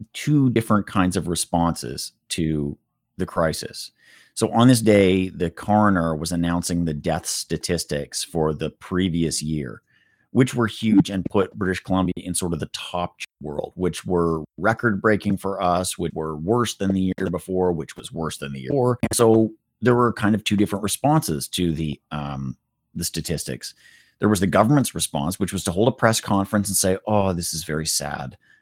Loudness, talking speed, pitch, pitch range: -22 LUFS, 185 wpm, 95 Hz, 85-105 Hz